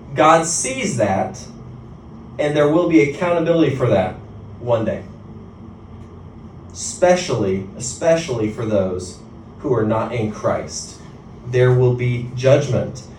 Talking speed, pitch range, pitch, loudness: 115 wpm, 110-140 Hz, 115 Hz, -18 LUFS